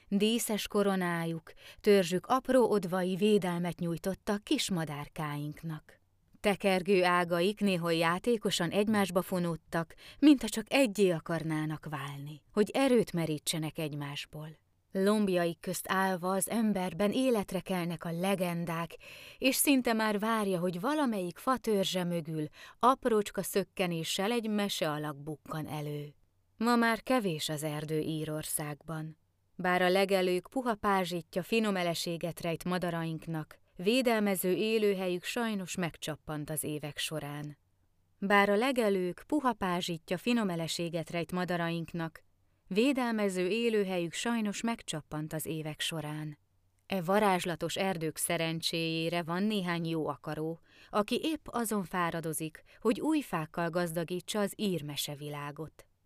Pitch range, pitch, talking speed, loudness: 160-205 Hz, 180 Hz, 110 wpm, -32 LUFS